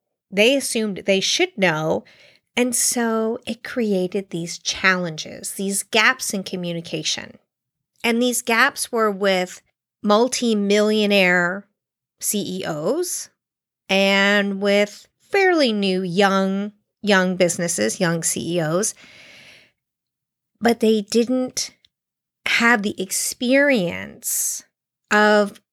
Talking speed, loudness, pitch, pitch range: 90 wpm, -20 LUFS, 205 Hz, 185-235 Hz